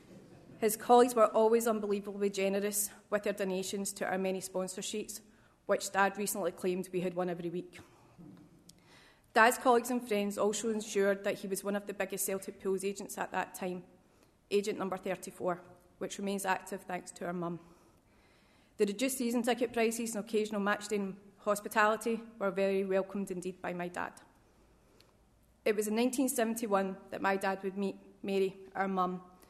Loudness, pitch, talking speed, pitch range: -33 LUFS, 195 Hz, 170 wpm, 185-210 Hz